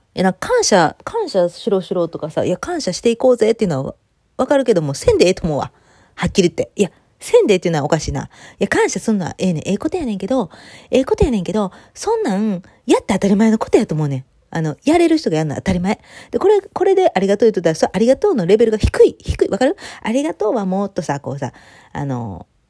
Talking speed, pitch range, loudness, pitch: 485 characters per minute, 175-265 Hz, -17 LUFS, 205 Hz